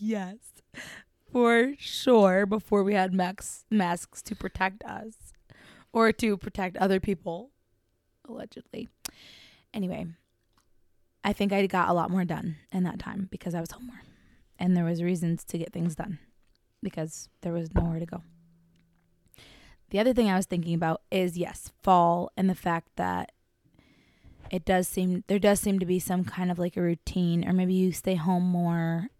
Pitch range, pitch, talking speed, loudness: 170-195 Hz, 180 Hz, 170 wpm, -27 LUFS